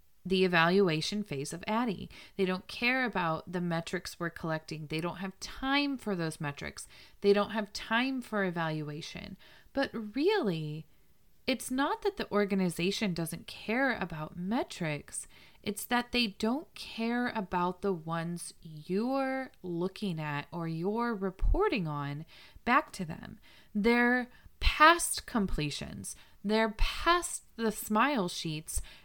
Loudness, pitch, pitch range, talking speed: -32 LUFS, 195 Hz, 165-240 Hz, 130 wpm